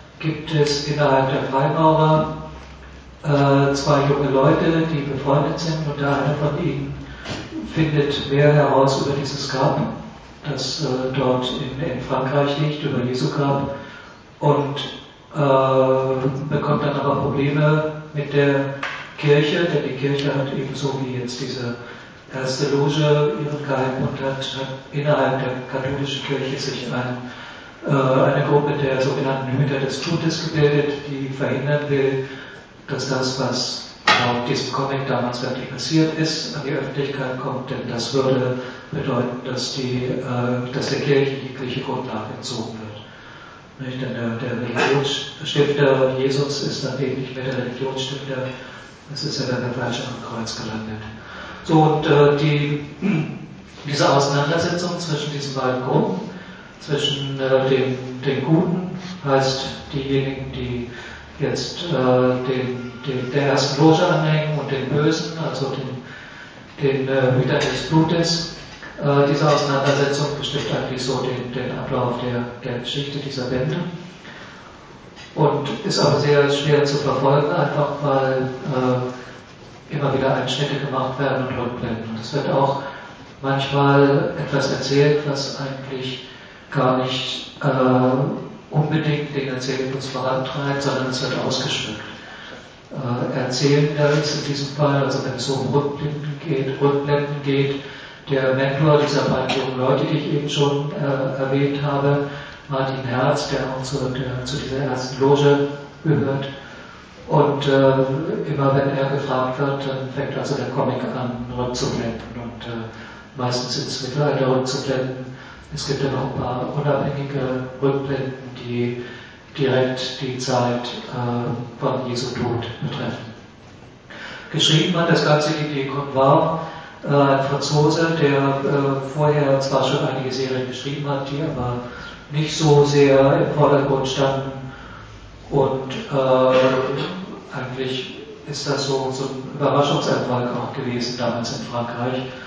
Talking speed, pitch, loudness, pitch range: 130 wpm, 135 Hz, -21 LUFS, 130-145 Hz